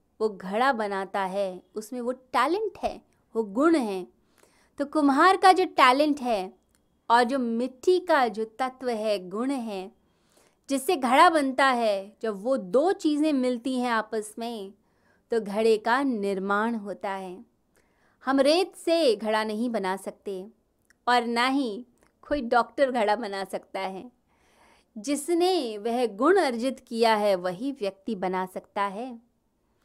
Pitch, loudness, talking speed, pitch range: 235 Hz, -25 LUFS, 145 wpm, 205-275 Hz